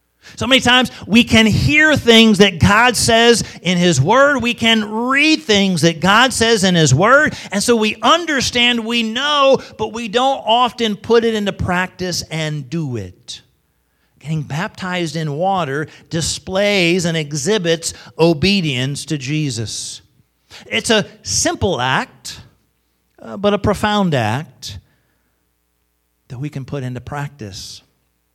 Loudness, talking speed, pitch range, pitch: -15 LUFS, 135 wpm, 135-230 Hz, 180 Hz